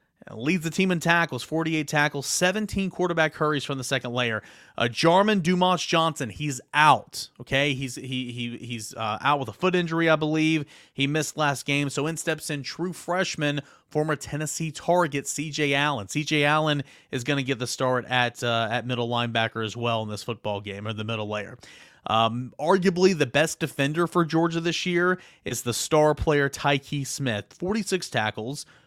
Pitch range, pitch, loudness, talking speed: 125-160 Hz, 145 Hz, -25 LUFS, 185 wpm